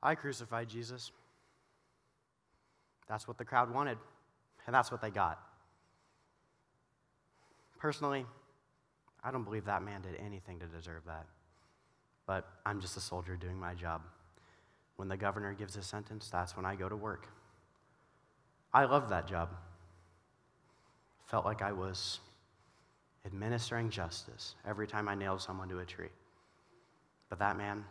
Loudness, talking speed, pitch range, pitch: -38 LUFS, 140 wpm, 90-120 Hz, 100 Hz